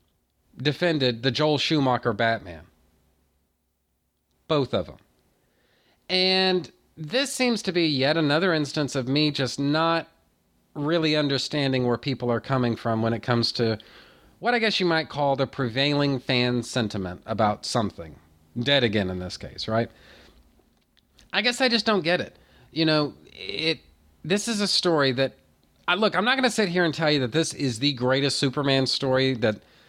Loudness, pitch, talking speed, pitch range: -24 LUFS, 135 Hz, 165 wpm, 110-160 Hz